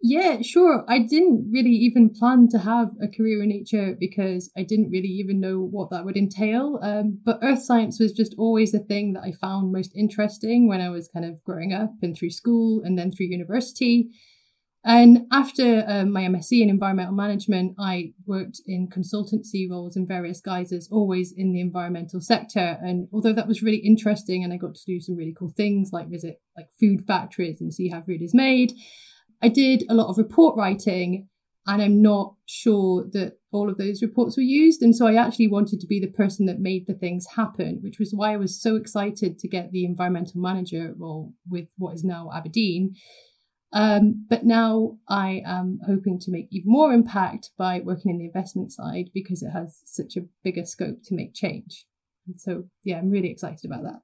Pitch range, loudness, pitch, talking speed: 185-225 Hz, -22 LUFS, 200 Hz, 205 wpm